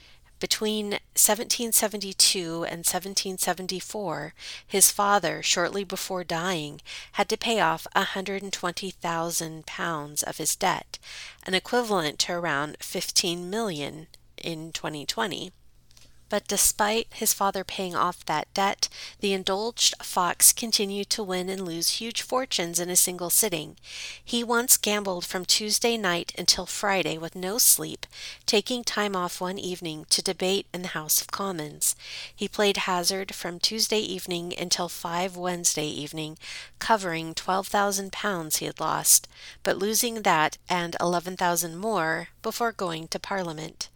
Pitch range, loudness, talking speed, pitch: 170-205 Hz, -25 LUFS, 135 wpm, 185 Hz